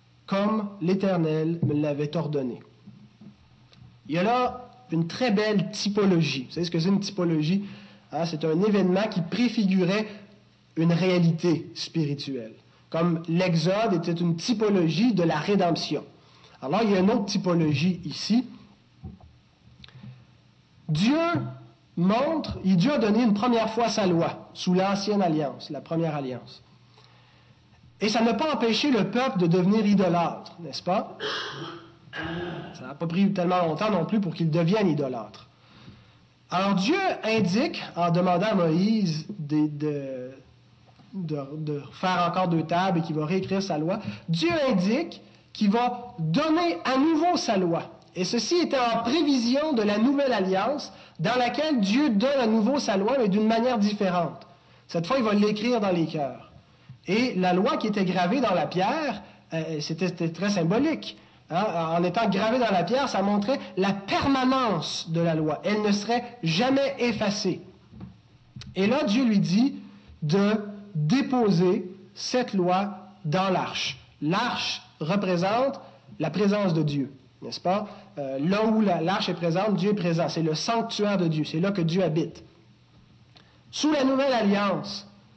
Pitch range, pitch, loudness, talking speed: 165-220 Hz, 185 Hz, -25 LUFS, 155 wpm